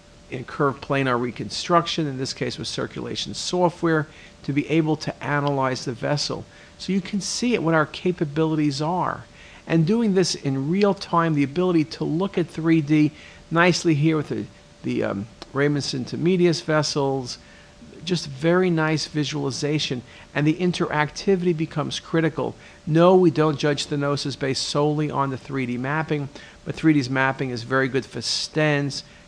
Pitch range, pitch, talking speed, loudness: 140-170 Hz, 150 Hz, 155 wpm, -23 LUFS